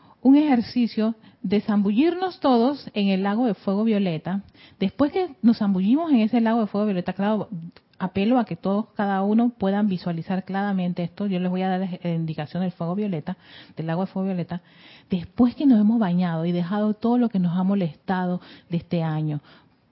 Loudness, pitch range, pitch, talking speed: -23 LUFS, 180-225 Hz, 195 Hz, 190 wpm